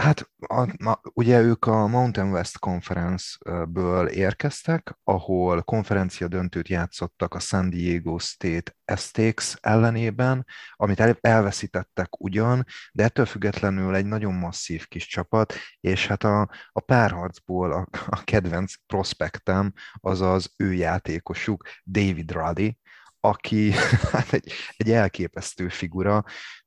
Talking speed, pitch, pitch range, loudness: 115 wpm, 95 Hz, 90-110 Hz, -24 LUFS